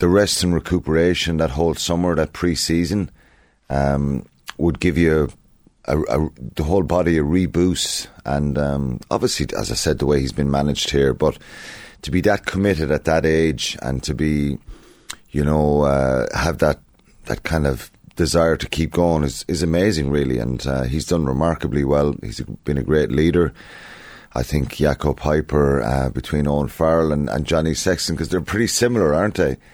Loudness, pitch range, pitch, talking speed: -20 LUFS, 70-85 Hz, 75 Hz, 180 wpm